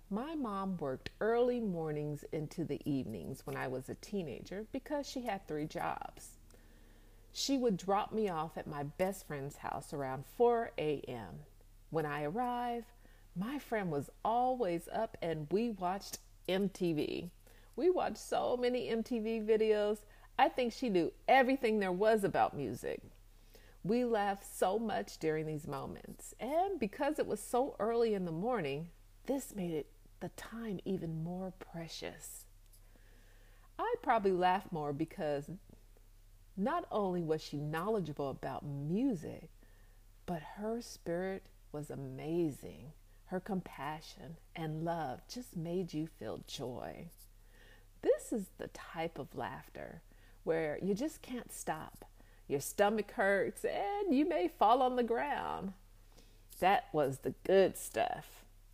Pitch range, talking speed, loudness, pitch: 145-225 Hz, 135 wpm, -37 LUFS, 175 Hz